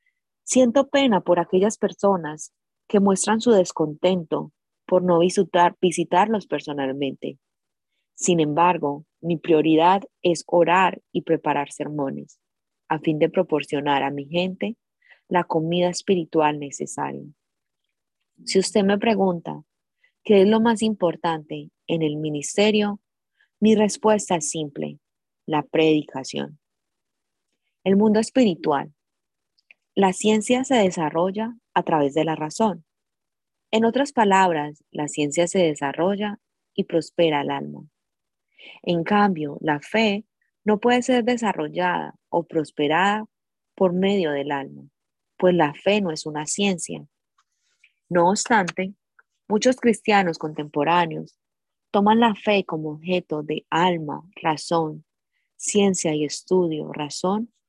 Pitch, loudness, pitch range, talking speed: 175 Hz, -22 LUFS, 155-205 Hz, 120 wpm